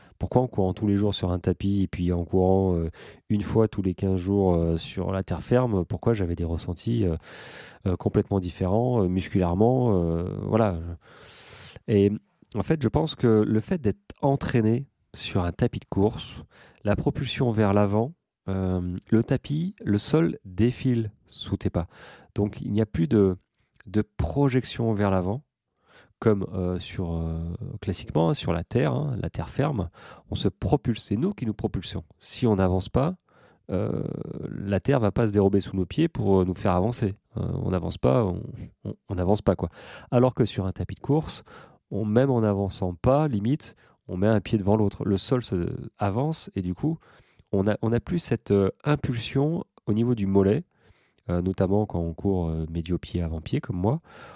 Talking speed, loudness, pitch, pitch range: 180 wpm, -26 LUFS, 105 Hz, 95-120 Hz